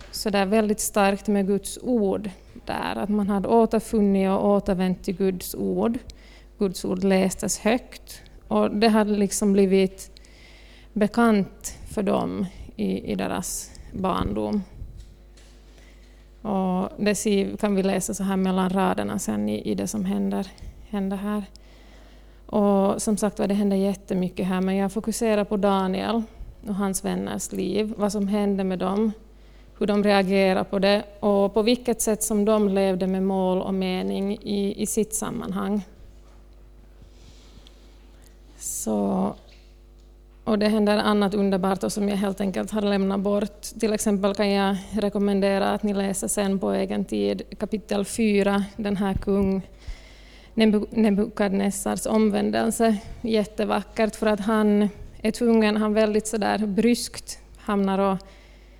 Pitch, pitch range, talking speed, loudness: 200 Hz, 190-210 Hz, 140 wpm, -24 LUFS